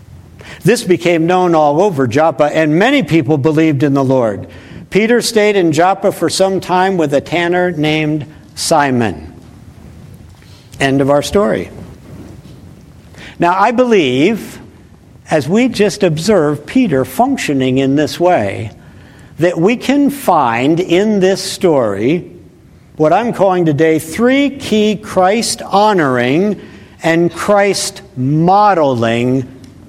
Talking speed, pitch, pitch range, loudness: 120 wpm, 160 Hz, 130-195 Hz, -12 LUFS